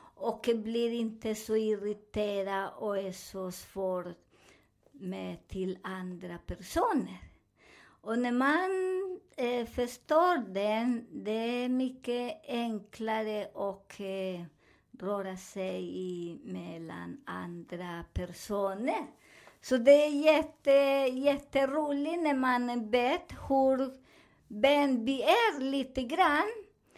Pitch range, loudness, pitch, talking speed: 195-275 Hz, -31 LUFS, 230 Hz, 100 wpm